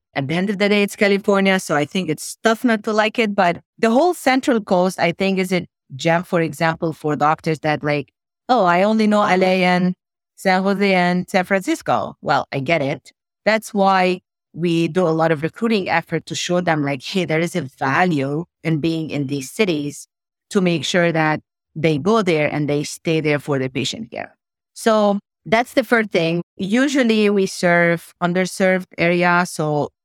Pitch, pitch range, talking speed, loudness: 180 Hz, 160-205 Hz, 195 wpm, -18 LUFS